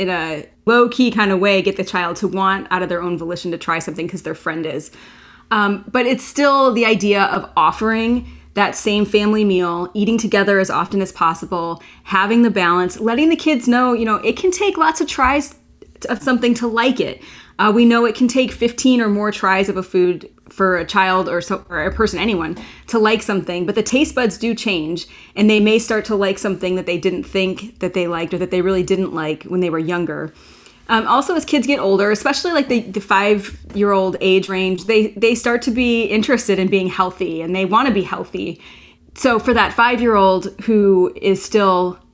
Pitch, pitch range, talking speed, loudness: 205 Hz, 185-235 Hz, 215 wpm, -17 LUFS